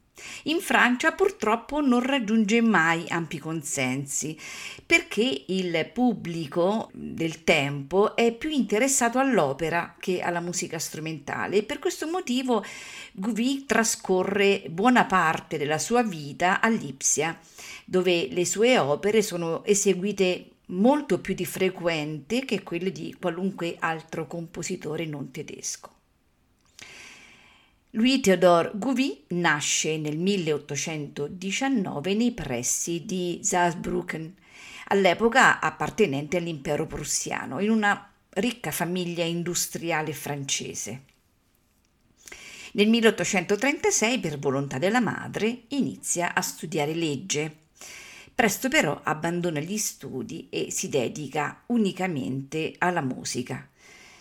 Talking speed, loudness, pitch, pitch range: 105 wpm, -25 LUFS, 185 Hz, 160-225 Hz